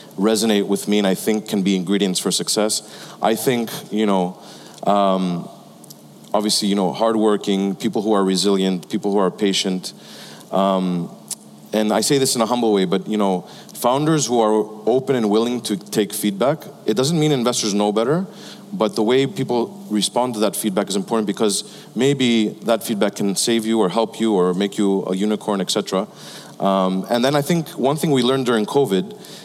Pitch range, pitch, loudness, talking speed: 100-125 Hz, 110 Hz, -19 LUFS, 185 wpm